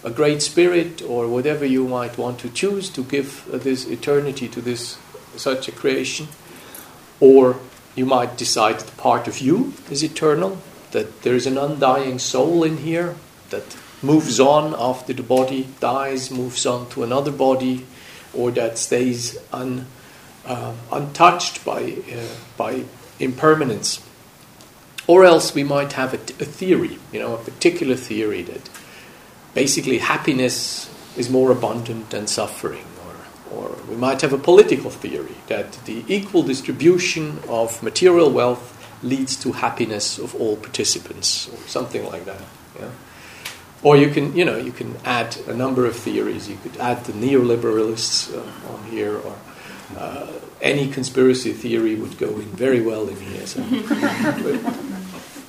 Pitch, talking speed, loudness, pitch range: 130 Hz, 155 wpm, -20 LUFS, 120-150 Hz